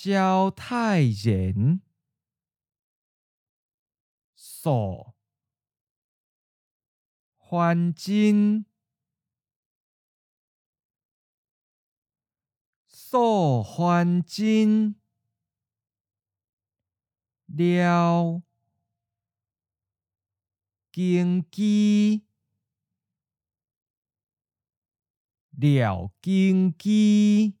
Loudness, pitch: -23 LUFS, 155 Hz